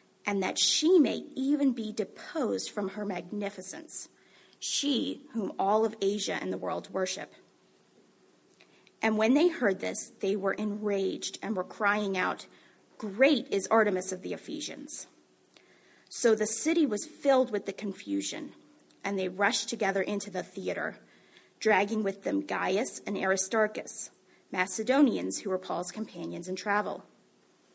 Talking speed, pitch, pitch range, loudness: 140 wpm, 205 Hz, 190-225 Hz, -29 LUFS